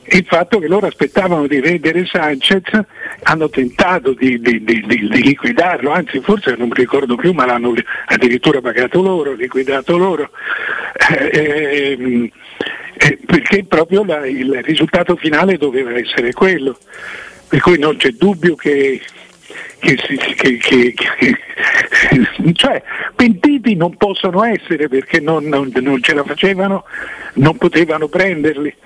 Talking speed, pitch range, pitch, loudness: 140 wpm, 135-195 Hz, 160 Hz, -13 LUFS